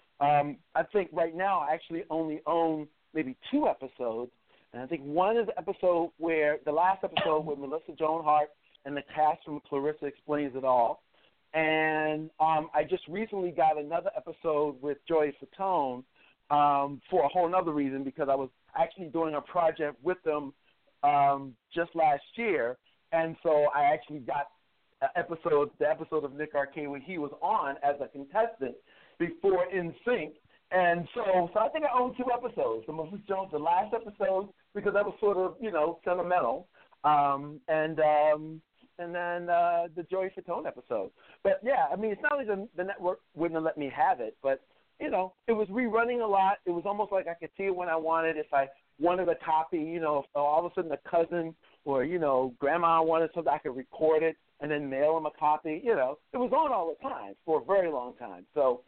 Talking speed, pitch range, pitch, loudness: 200 wpm, 150-185 Hz, 160 Hz, -30 LUFS